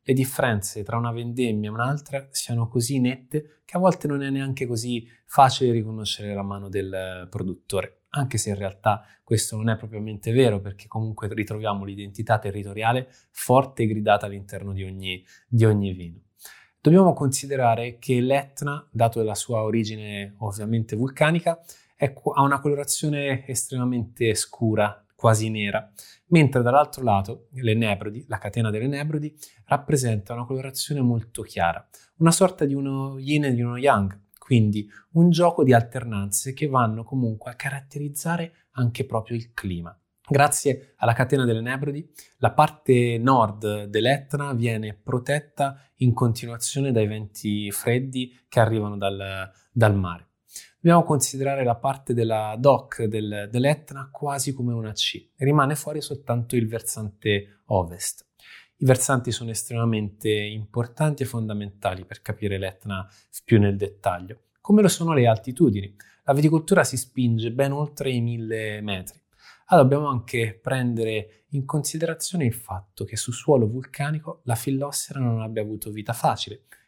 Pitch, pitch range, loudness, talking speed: 120 Hz, 105-140 Hz, -24 LUFS, 145 wpm